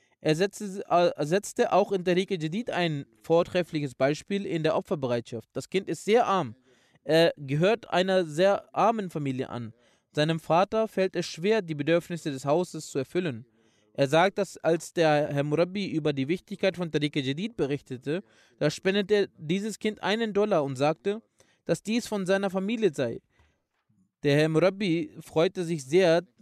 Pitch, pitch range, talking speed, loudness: 170 Hz, 150-195 Hz, 155 wpm, -27 LUFS